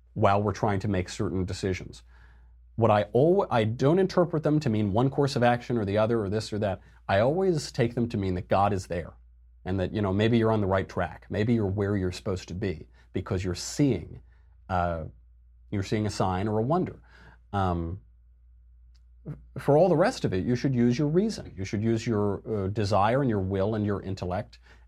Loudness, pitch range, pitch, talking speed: -27 LUFS, 85-115 Hz, 100 Hz, 215 wpm